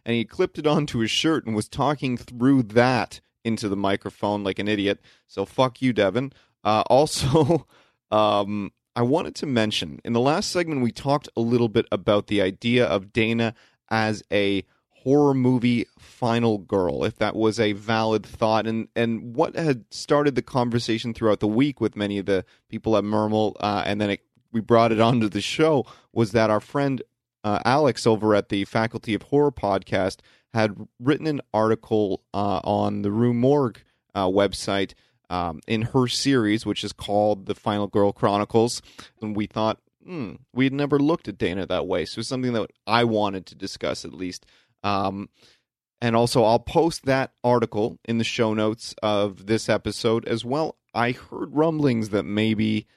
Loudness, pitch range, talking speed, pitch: -23 LUFS, 105-125 Hz, 180 wpm, 110 Hz